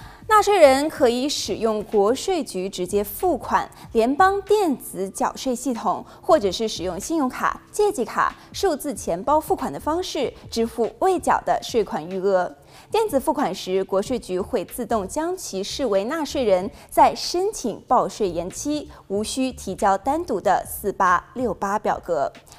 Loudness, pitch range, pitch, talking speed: -22 LUFS, 195-310 Hz, 245 Hz, 235 characters per minute